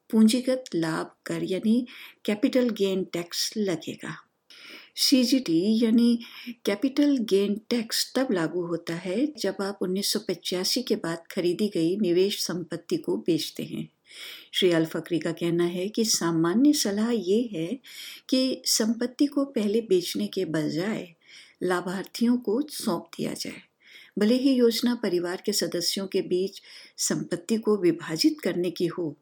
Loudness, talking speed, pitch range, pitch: -26 LUFS, 135 wpm, 175-245 Hz, 205 Hz